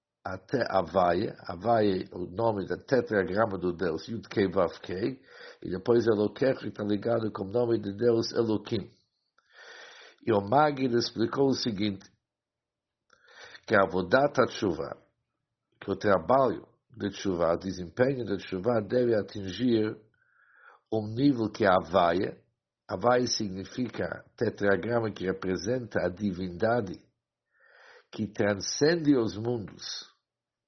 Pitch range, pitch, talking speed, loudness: 95-120 Hz, 110 Hz, 120 wpm, -28 LUFS